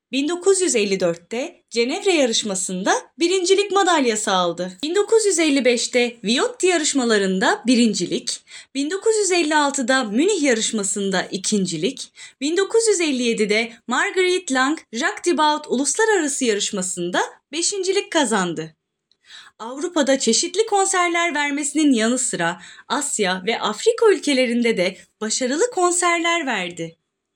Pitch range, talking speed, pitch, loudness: 215-350 Hz, 80 wpm, 265 Hz, -19 LUFS